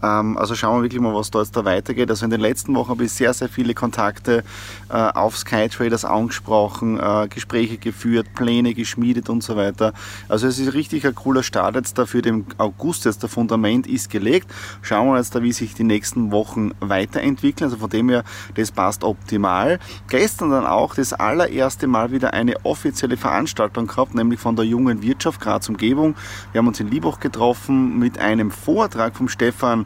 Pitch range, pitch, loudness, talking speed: 105-120 Hz, 115 Hz, -20 LUFS, 190 wpm